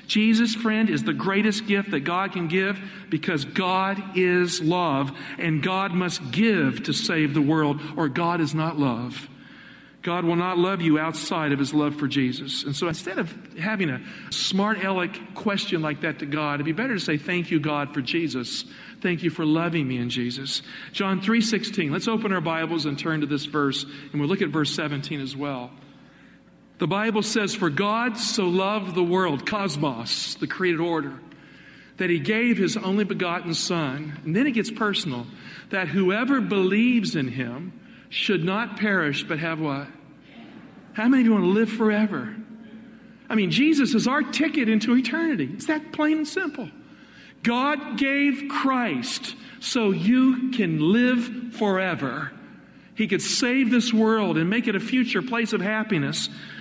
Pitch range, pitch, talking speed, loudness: 160-230 Hz, 190 Hz, 175 wpm, -24 LUFS